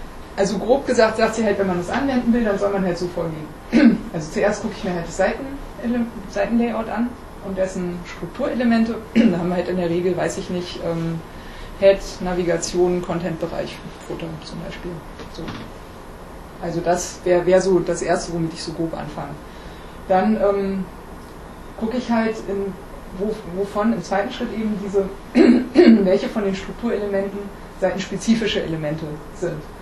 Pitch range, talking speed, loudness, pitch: 175-215 Hz, 160 wpm, -21 LUFS, 195 Hz